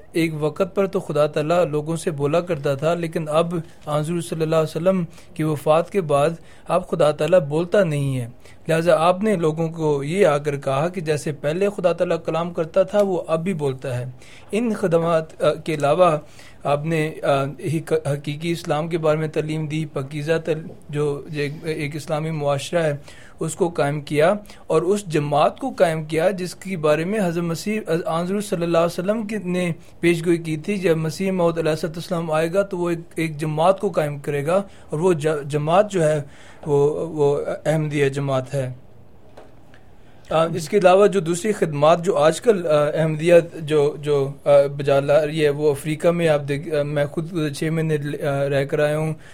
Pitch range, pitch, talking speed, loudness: 150-175 Hz, 160 Hz, 180 wpm, -21 LUFS